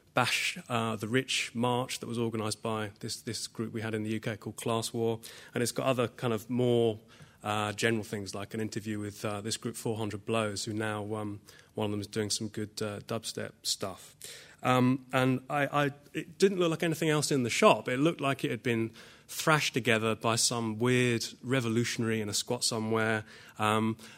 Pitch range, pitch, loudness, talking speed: 110-125 Hz, 115 Hz, -31 LUFS, 205 wpm